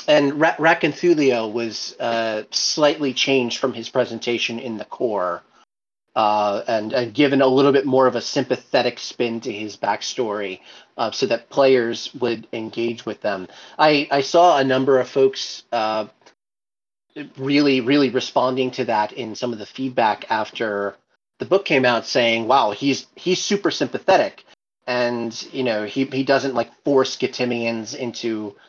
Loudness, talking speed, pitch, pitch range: -20 LUFS, 155 wpm, 125 Hz, 115-135 Hz